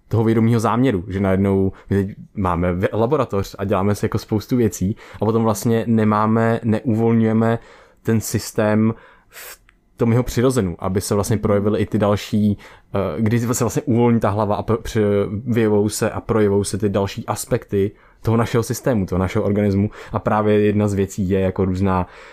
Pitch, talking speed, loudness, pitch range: 105 Hz, 165 wpm, -19 LUFS, 100-115 Hz